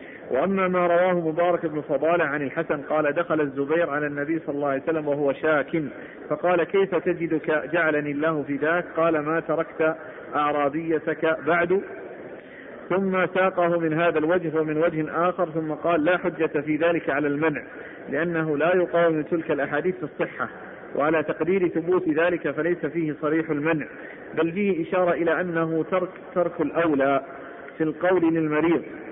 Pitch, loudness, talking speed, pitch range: 160 Hz, -24 LUFS, 150 wpm, 155-170 Hz